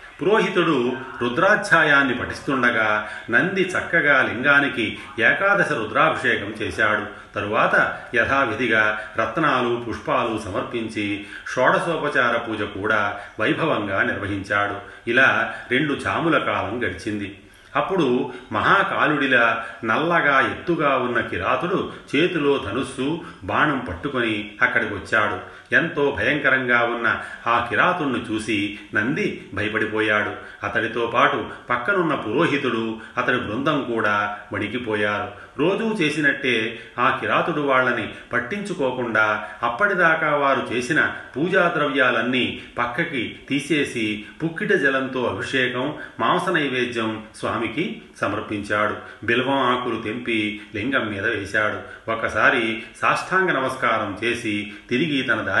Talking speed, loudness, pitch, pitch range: 90 wpm, -21 LUFS, 120 Hz, 105-140 Hz